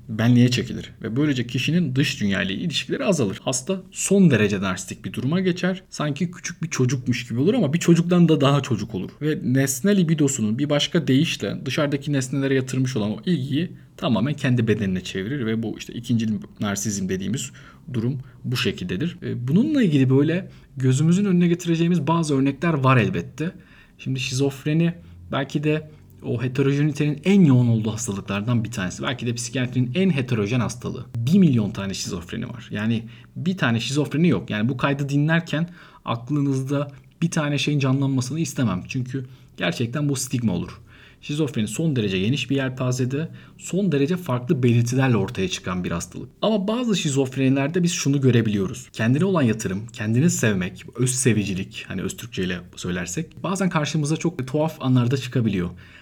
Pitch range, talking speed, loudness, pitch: 115-155 Hz, 155 wpm, -22 LUFS, 135 Hz